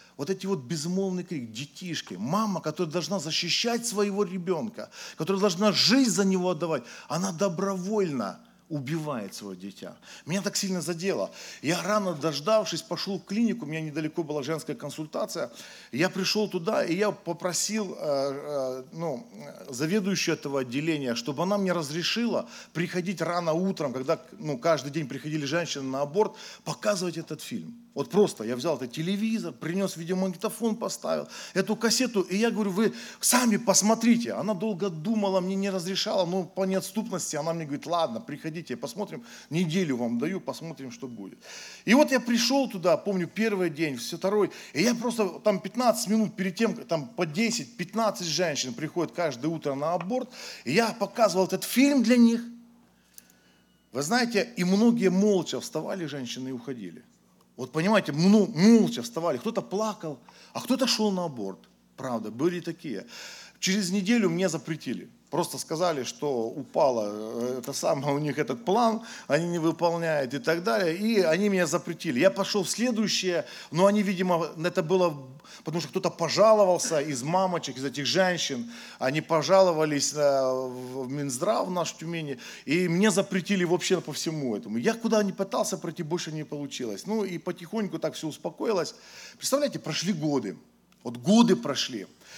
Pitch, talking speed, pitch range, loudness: 180 Hz, 155 wpm, 155-205 Hz, -27 LUFS